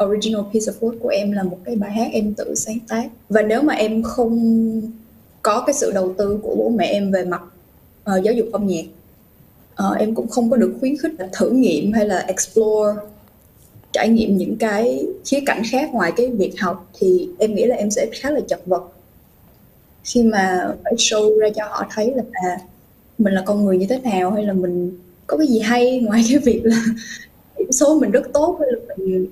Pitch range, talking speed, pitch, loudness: 200-245 Hz, 215 wpm, 220 Hz, -19 LUFS